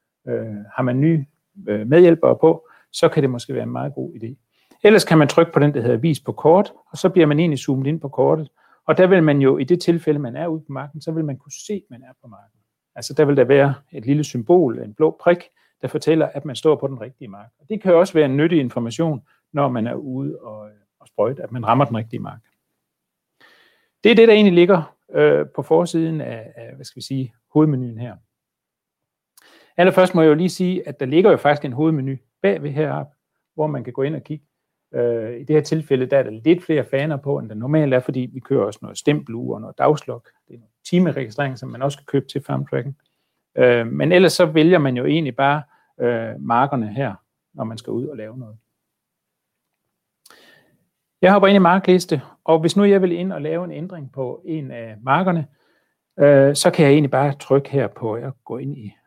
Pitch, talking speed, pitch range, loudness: 145 Hz, 230 wpm, 130-165 Hz, -18 LUFS